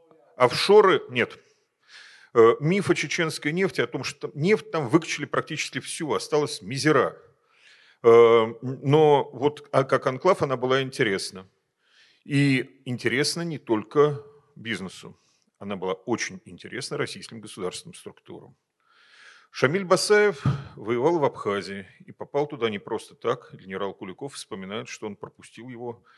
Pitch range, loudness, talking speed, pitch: 125-165 Hz, -24 LUFS, 120 wpm, 145 Hz